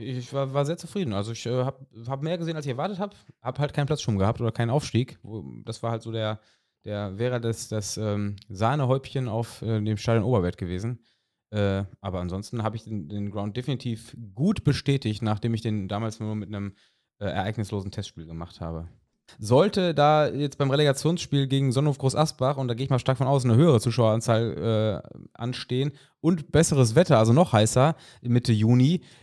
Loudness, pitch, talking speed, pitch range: -25 LUFS, 120 Hz, 195 wpm, 110-140 Hz